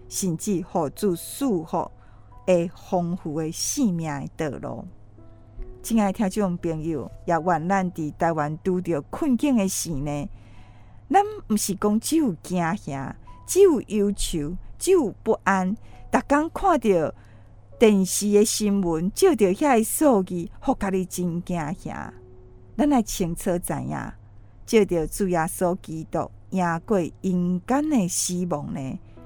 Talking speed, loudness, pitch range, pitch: 190 characters per minute, -24 LUFS, 155-210 Hz, 180 Hz